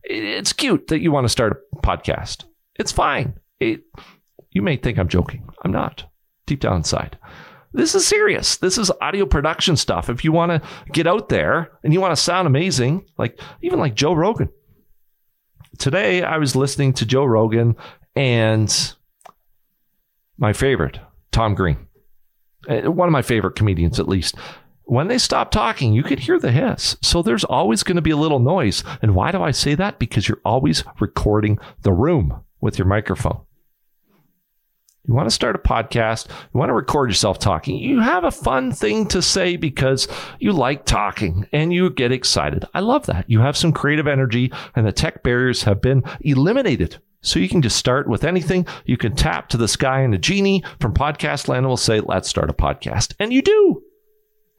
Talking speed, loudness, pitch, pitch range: 185 wpm, -19 LUFS, 135 Hz, 110-175 Hz